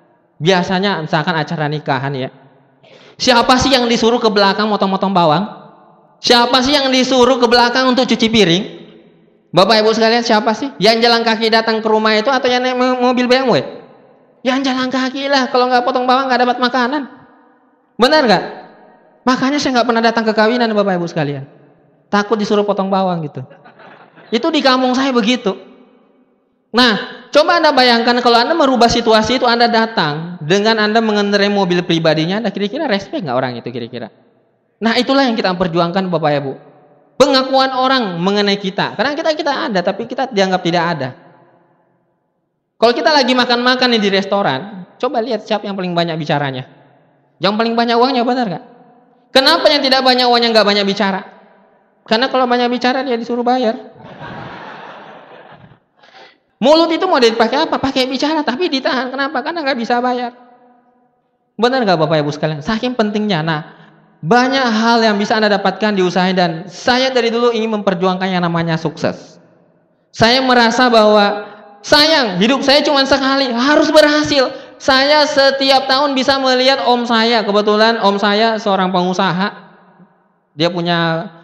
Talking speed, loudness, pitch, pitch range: 155 wpm, -13 LUFS, 225 Hz, 190-255 Hz